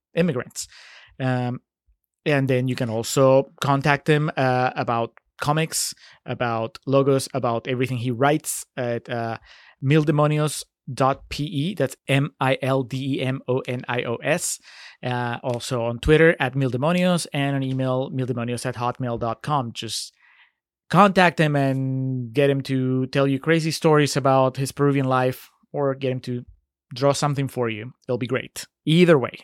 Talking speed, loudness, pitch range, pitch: 150 wpm, -22 LUFS, 125-145 Hz, 130 Hz